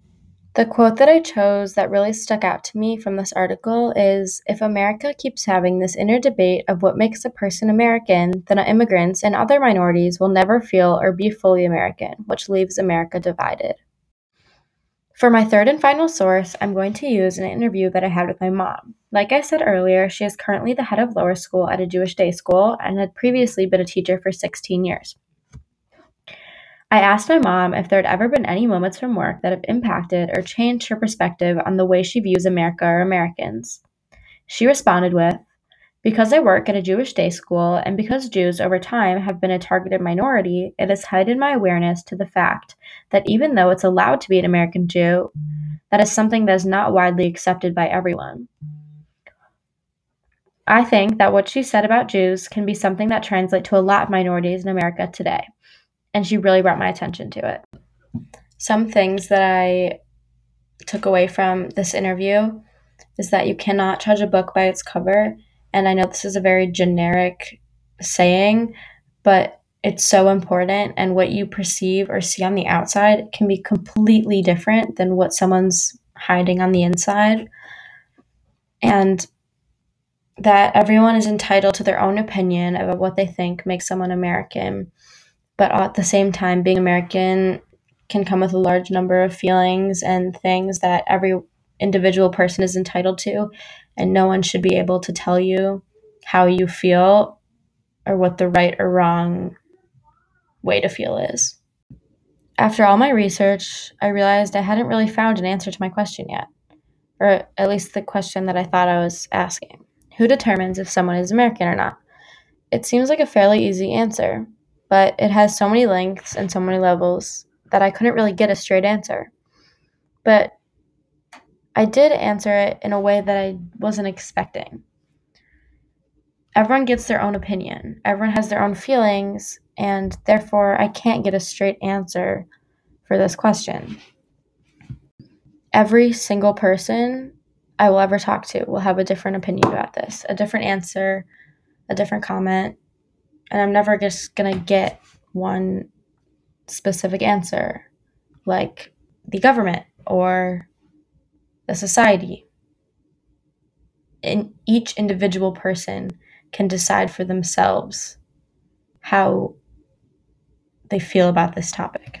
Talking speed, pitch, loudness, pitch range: 170 wpm, 195 Hz, -18 LUFS, 185-210 Hz